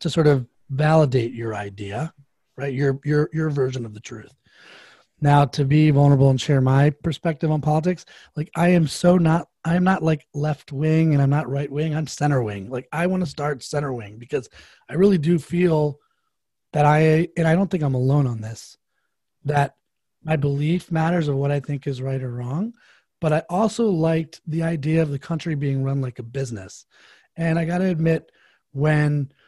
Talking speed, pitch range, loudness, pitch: 195 wpm, 135-165 Hz, -21 LUFS, 150 Hz